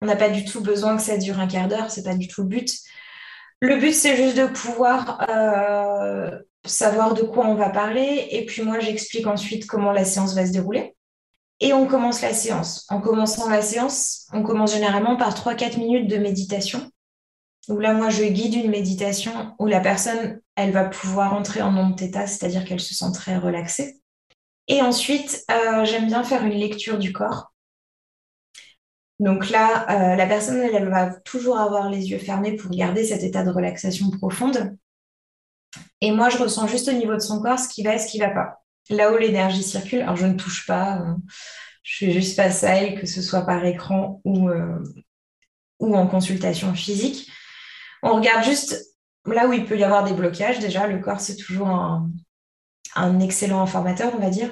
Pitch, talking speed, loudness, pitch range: 210 Hz, 200 wpm, -21 LUFS, 190-225 Hz